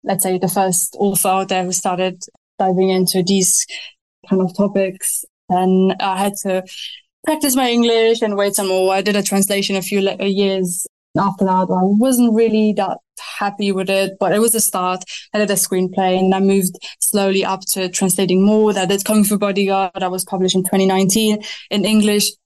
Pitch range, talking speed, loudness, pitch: 185-205 Hz, 190 wpm, -16 LUFS, 195 Hz